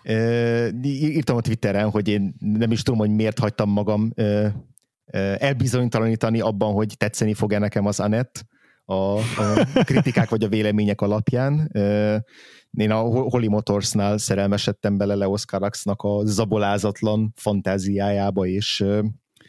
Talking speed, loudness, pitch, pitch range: 120 wpm, -22 LUFS, 105 Hz, 100-115 Hz